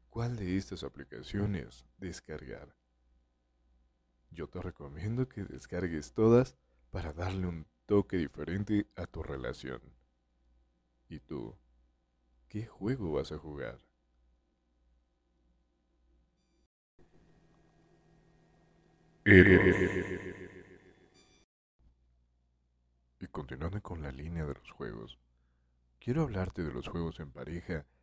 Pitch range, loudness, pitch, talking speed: 60-90 Hz, -32 LUFS, 70 Hz, 90 wpm